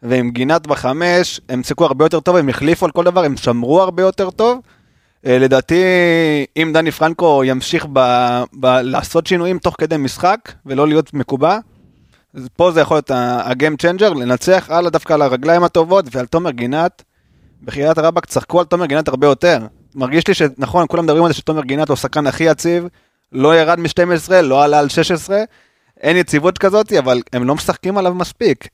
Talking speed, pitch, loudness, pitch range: 180 wpm, 160 Hz, -14 LUFS, 135-175 Hz